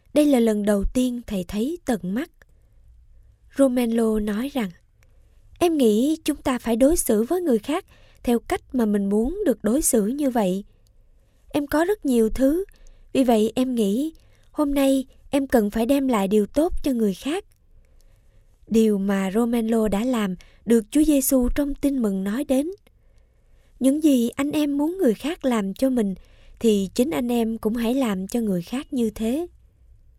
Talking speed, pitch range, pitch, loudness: 175 wpm, 220-280 Hz, 245 Hz, -22 LUFS